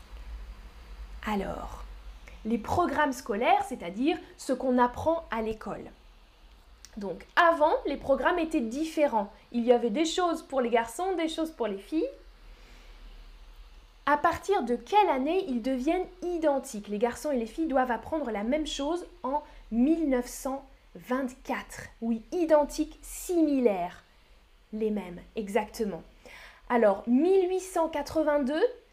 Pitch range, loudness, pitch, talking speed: 230-320 Hz, -29 LUFS, 275 Hz, 120 wpm